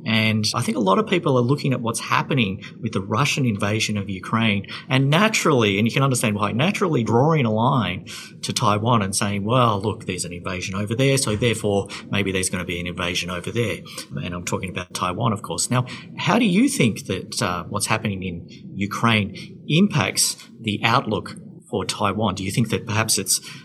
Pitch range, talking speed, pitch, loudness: 100-125 Hz, 205 wpm, 110 Hz, -21 LUFS